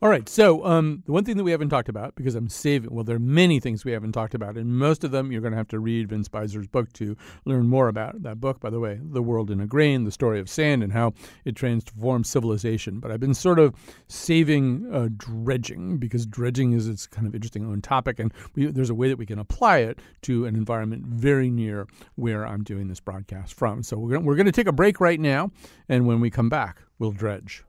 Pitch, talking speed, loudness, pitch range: 120 Hz, 255 wpm, -24 LUFS, 110-135 Hz